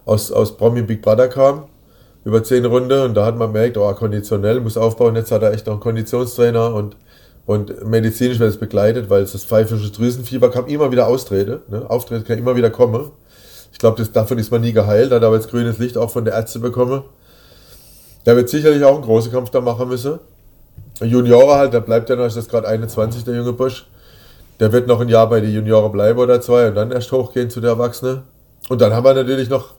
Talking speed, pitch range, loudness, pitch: 220 wpm, 110-125 Hz, -15 LUFS, 120 Hz